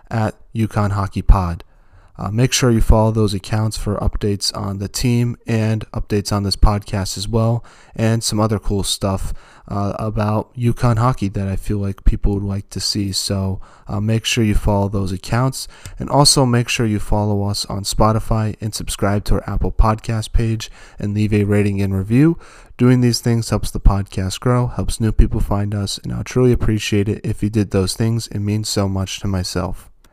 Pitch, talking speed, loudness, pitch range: 105 Hz, 195 wpm, -19 LUFS, 100-115 Hz